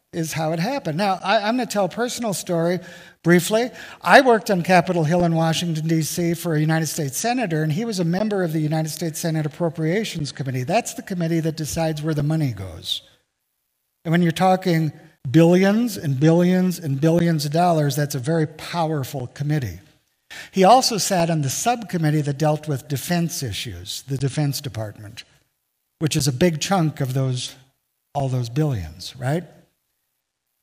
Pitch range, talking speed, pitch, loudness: 145-175 Hz, 175 wpm, 160 Hz, -21 LUFS